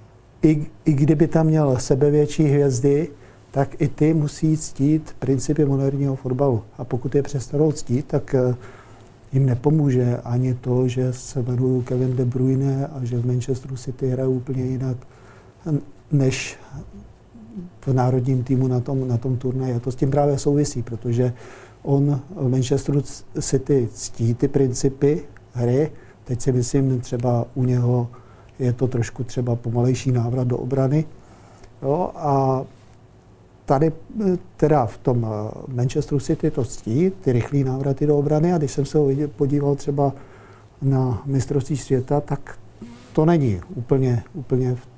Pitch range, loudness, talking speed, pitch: 125-145 Hz, -21 LUFS, 140 wpm, 130 Hz